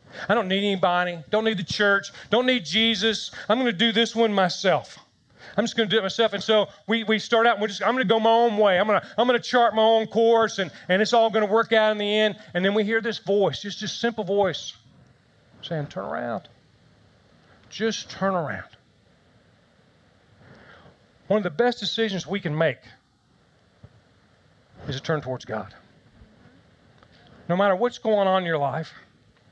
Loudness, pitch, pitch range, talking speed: -23 LUFS, 205 Hz, 175-225 Hz, 200 wpm